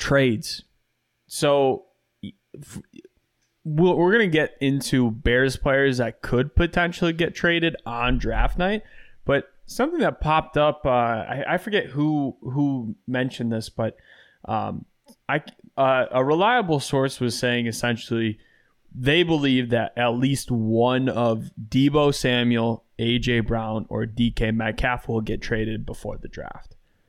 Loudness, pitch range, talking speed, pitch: -23 LUFS, 115-145 Hz, 130 wpm, 125 Hz